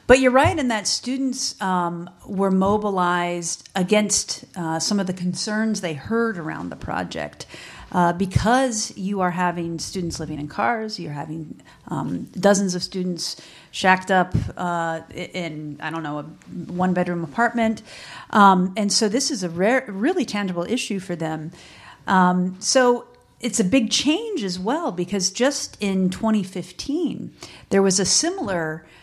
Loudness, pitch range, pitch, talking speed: -22 LUFS, 175-225 Hz, 190 Hz, 155 wpm